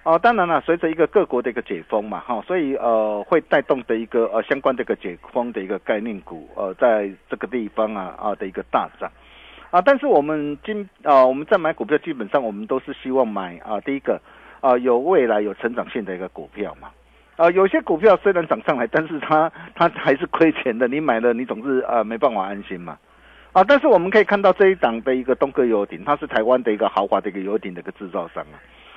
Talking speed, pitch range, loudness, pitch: 360 characters per minute, 115-170 Hz, -20 LUFS, 140 Hz